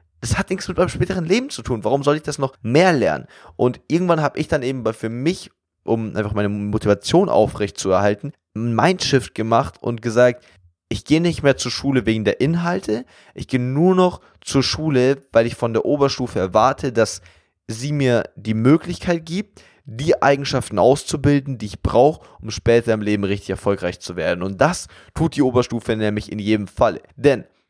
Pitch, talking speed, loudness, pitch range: 125 Hz, 190 wpm, -19 LUFS, 110-145 Hz